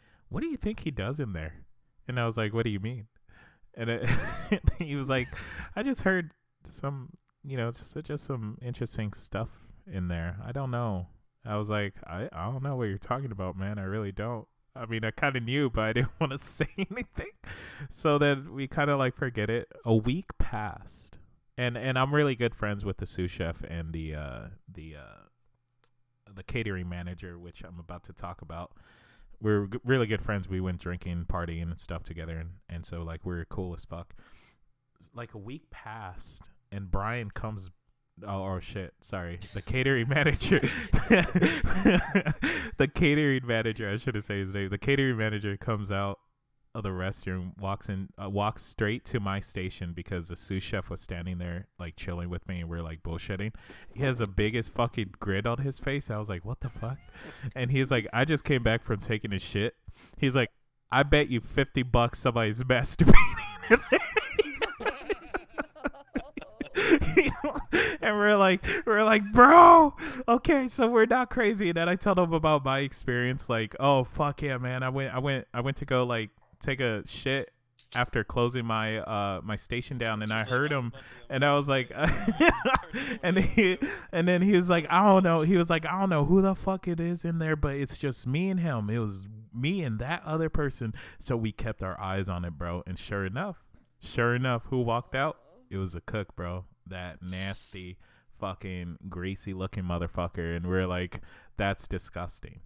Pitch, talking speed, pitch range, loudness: 115 Hz, 195 wpm, 95-140 Hz, -28 LUFS